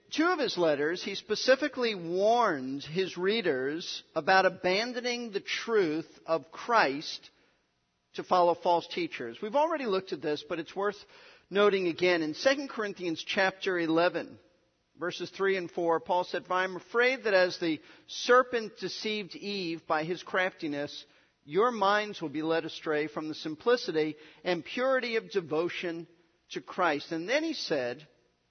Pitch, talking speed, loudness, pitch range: 180 Hz, 150 wpm, -30 LUFS, 165-215 Hz